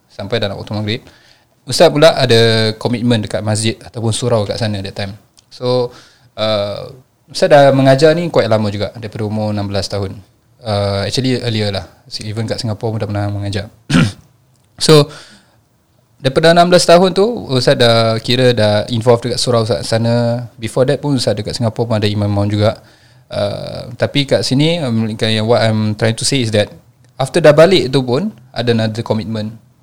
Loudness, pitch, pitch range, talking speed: -14 LUFS, 115 Hz, 110-130 Hz, 170 wpm